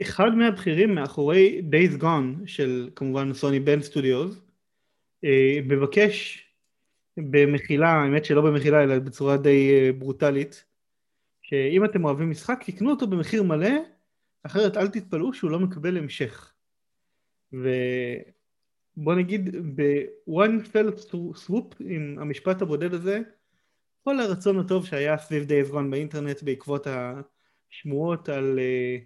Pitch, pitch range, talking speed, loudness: 155 Hz, 140-195 Hz, 110 wpm, -24 LUFS